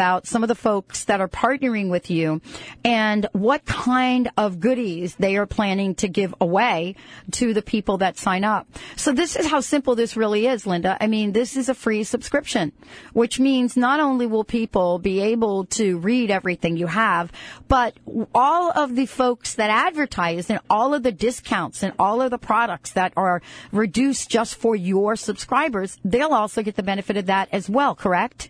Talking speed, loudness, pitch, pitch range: 190 wpm, -21 LUFS, 215 Hz, 195-245 Hz